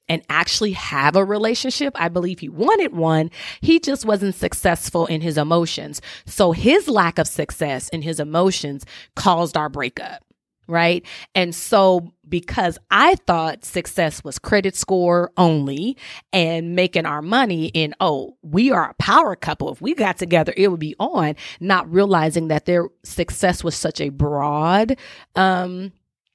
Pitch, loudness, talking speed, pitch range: 175 Hz, -19 LUFS, 155 wpm, 160-195 Hz